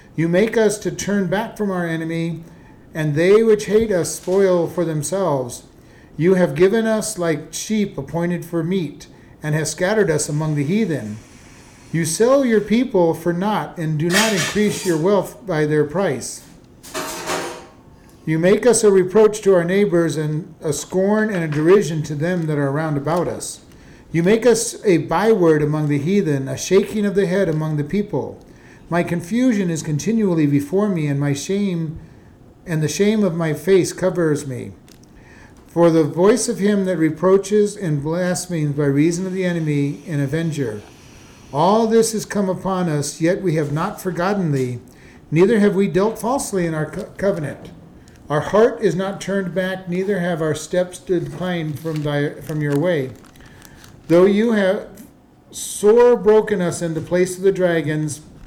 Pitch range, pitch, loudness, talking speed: 155-195 Hz, 175 Hz, -19 LUFS, 170 wpm